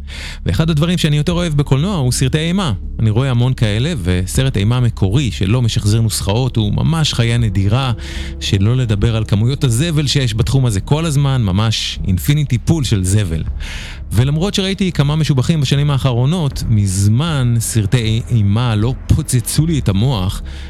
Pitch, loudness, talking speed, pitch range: 120 Hz, -15 LUFS, 150 wpm, 105-145 Hz